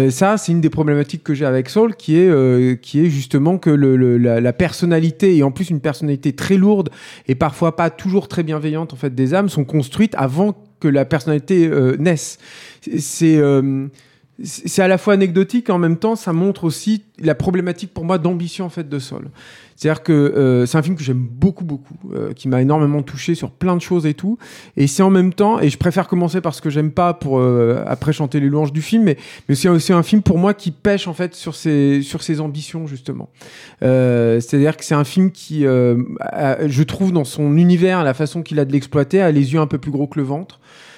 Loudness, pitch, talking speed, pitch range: -16 LUFS, 155 Hz, 235 wpm, 140-180 Hz